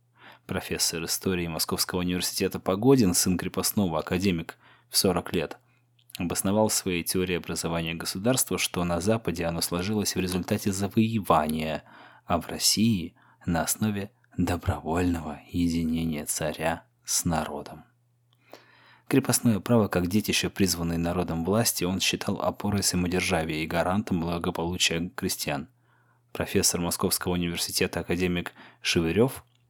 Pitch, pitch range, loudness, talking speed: 90 Hz, 85-105 Hz, -26 LUFS, 110 wpm